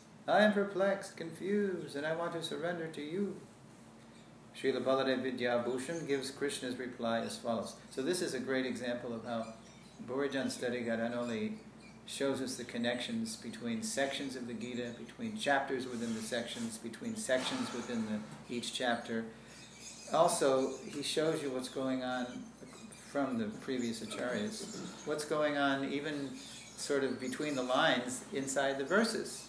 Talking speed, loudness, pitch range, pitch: 150 wpm, -36 LUFS, 120-160 Hz, 135 Hz